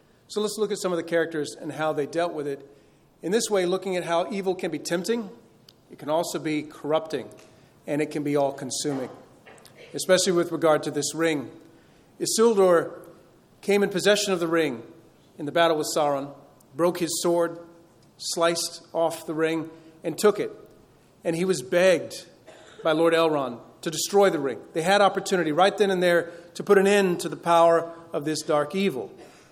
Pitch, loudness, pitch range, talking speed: 170 Hz, -24 LUFS, 155-185 Hz, 185 wpm